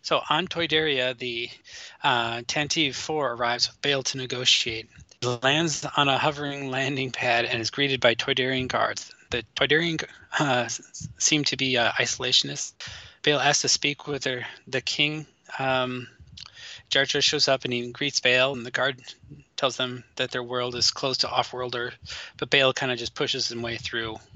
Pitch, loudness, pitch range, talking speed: 130 Hz, -24 LUFS, 120-145 Hz, 170 wpm